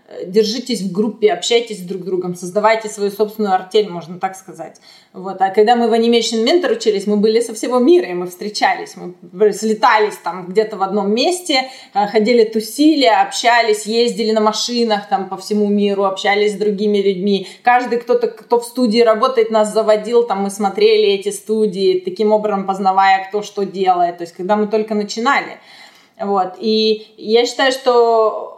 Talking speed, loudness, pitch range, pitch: 170 wpm, -15 LUFS, 195-235 Hz, 215 Hz